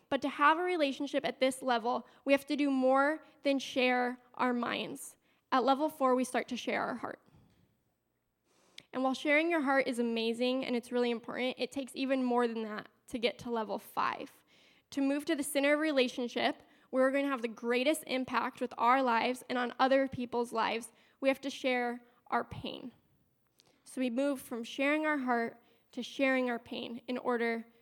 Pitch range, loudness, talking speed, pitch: 245-275 Hz, -32 LUFS, 195 wpm, 255 Hz